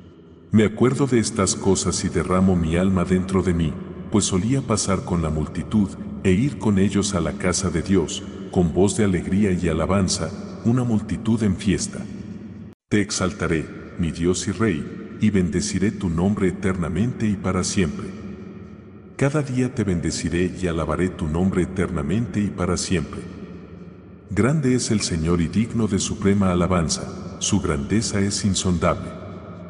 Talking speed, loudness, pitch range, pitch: 155 wpm, -22 LUFS, 90-105 Hz, 95 Hz